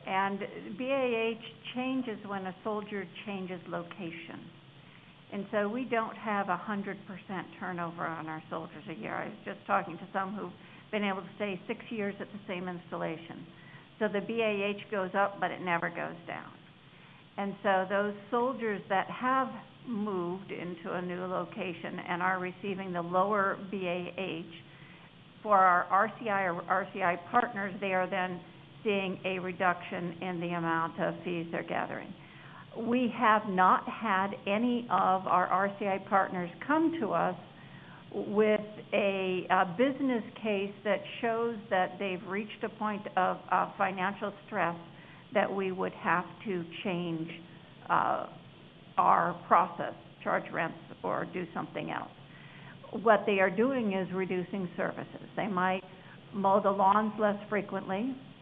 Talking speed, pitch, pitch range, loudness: 145 wpm, 190 Hz, 175-210 Hz, -32 LUFS